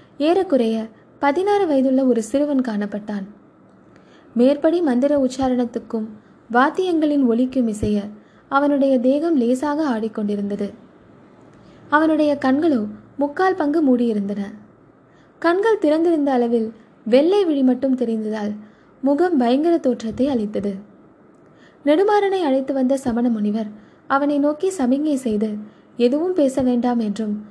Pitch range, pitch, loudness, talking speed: 225-295 Hz, 260 Hz, -19 LUFS, 95 wpm